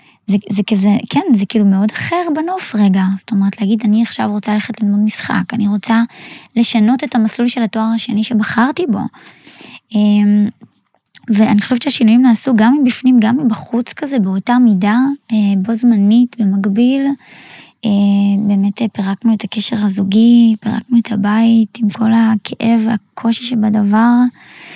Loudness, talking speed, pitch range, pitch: -13 LUFS, 135 wpm, 210-235 Hz, 220 Hz